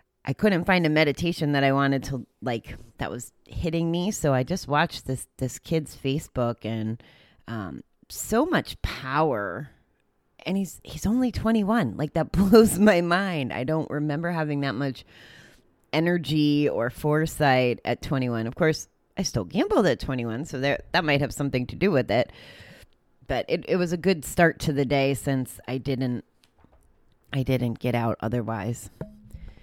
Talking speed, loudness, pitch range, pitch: 175 wpm, -25 LUFS, 120-160 Hz, 140 Hz